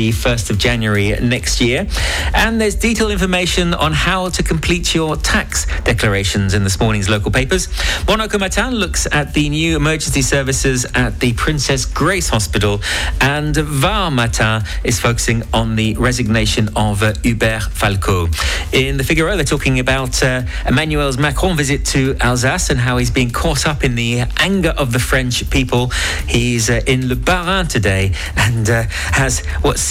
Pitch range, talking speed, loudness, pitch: 110-150 Hz, 165 wpm, -15 LUFS, 125 Hz